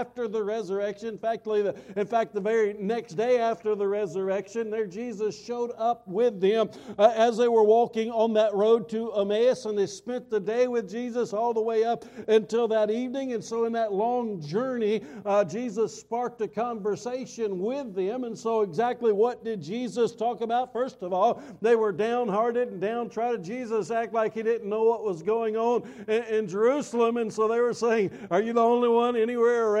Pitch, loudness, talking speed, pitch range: 225 Hz, -26 LUFS, 195 wpm, 215-235 Hz